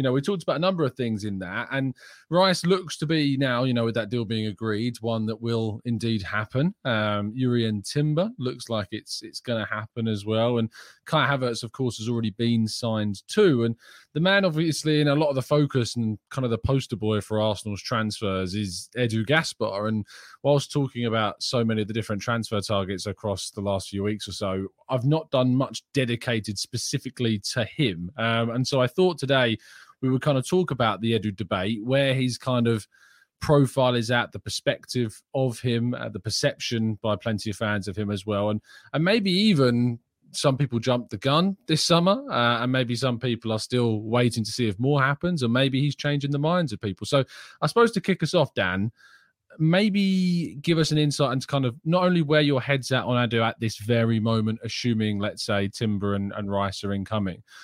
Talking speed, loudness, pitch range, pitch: 215 wpm, -25 LUFS, 110-140 Hz, 120 Hz